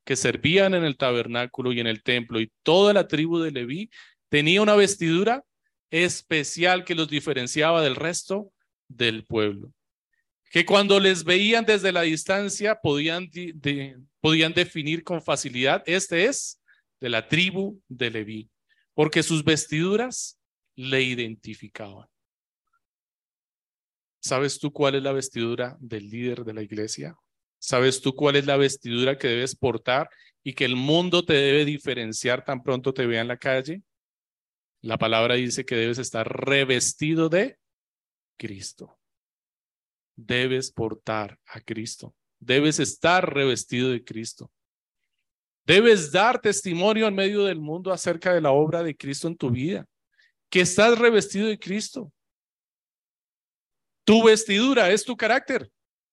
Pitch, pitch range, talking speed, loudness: 150 Hz, 125-185 Hz, 140 wpm, -23 LUFS